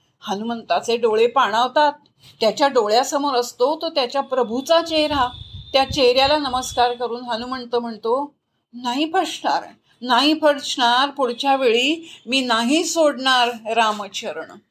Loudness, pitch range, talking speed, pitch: -19 LUFS, 240-295 Hz, 105 wpm, 255 Hz